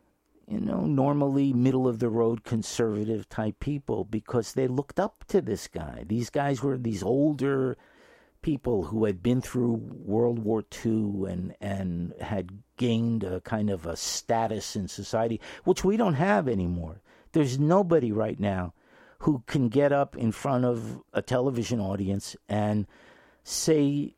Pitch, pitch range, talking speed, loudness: 115 Hz, 105-140 Hz, 155 wpm, -28 LUFS